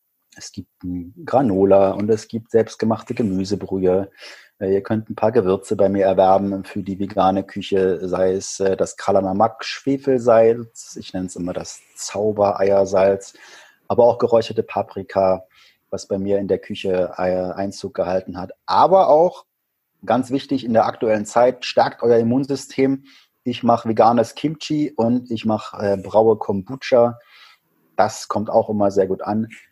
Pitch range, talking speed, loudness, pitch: 95-115 Hz, 140 wpm, -19 LUFS, 100 Hz